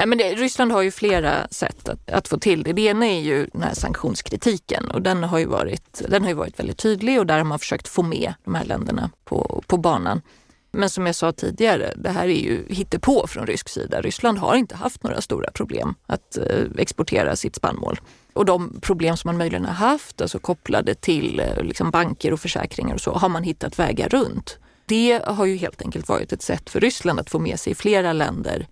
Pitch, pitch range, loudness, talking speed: 195 Hz, 170-225 Hz, -22 LUFS, 225 wpm